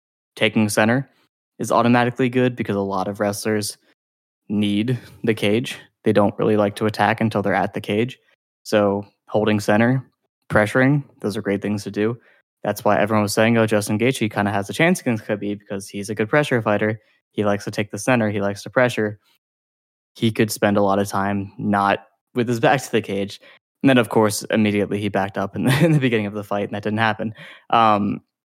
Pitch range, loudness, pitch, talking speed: 100-115 Hz, -20 LUFS, 105 Hz, 210 wpm